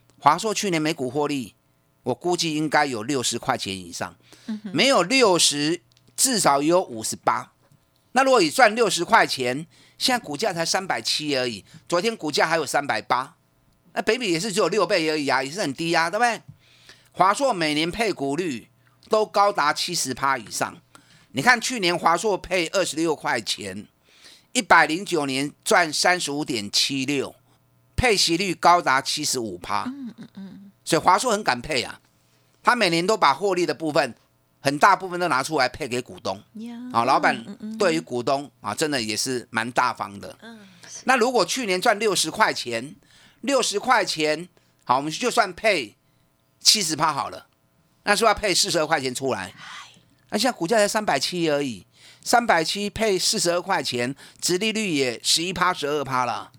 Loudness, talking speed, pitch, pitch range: -22 LUFS, 255 characters per minute, 165 Hz, 130-205 Hz